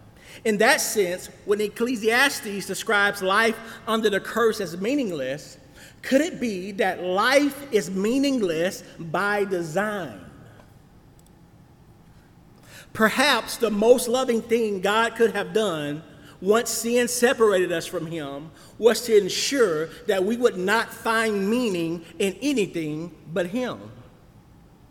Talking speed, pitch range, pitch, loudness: 120 wpm, 185-230 Hz, 210 Hz, -23 LUFS